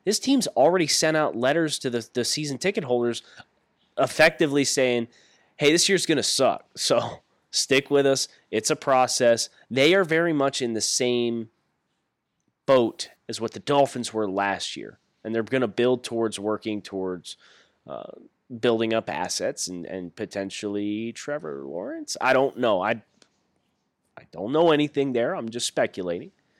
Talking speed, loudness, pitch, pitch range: 160 wpm, -24 LUFS, 120 Hz, 110-145 Hz